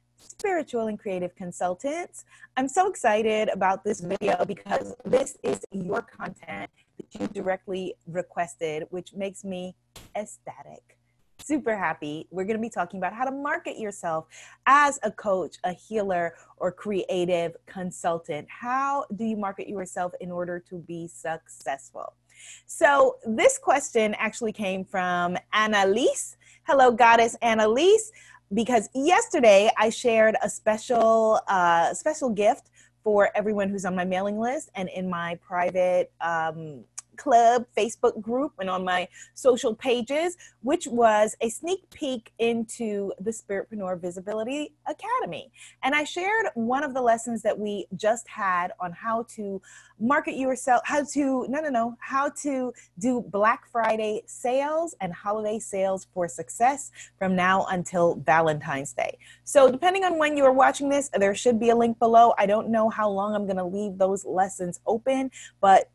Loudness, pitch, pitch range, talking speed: -25 LUFS, 215 Hz, 185-260 Hz, 150 wpm